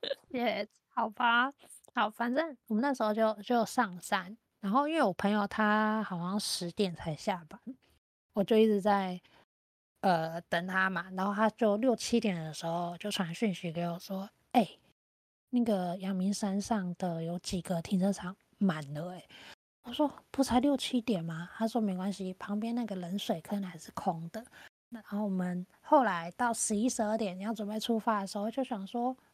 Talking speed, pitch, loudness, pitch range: 255 characters per minute, 205 Hz, -32 LUFS, 185-230 Hz